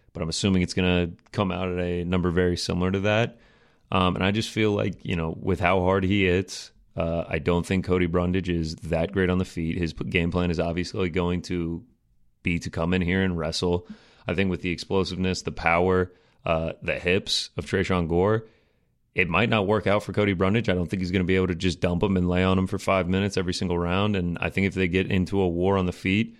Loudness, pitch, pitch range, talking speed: -25 LUFS, 90 Hz, 85-95 Hz, 250 wpm